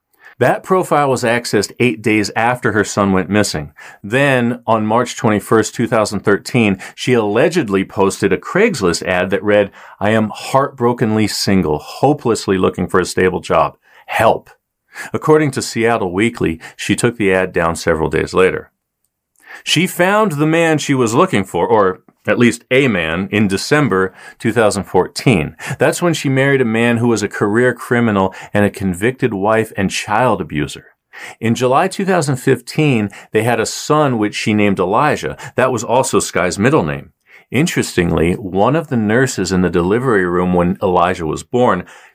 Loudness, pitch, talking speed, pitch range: -15 LUFS, 115 Hz, 160 wpm, 100-130 Hz